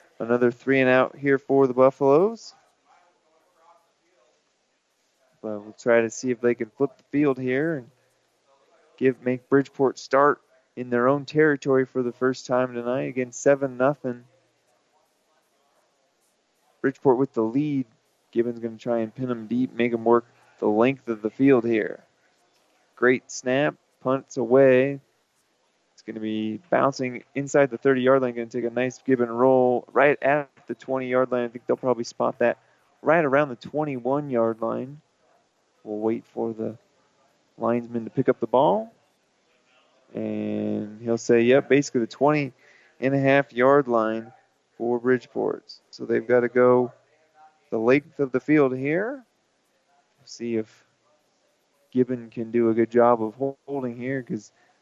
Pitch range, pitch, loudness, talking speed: 120-135 Hz, 130 Hz, -23 LUFS, 160 wpm